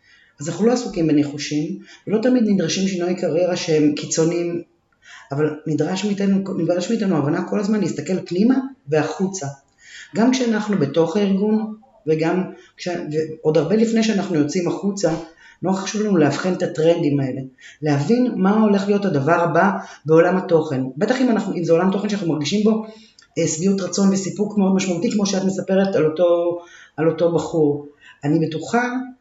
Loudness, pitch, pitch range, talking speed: -20 LUFS, 175 Hz, 160-205 Hz, 155 wpm